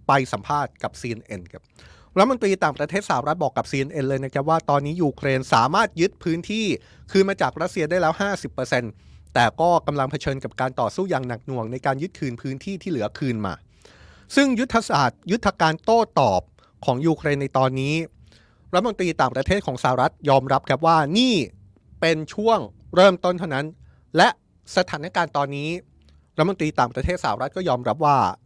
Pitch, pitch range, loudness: 145 Hz, 130-180 Hz, -22 LUFS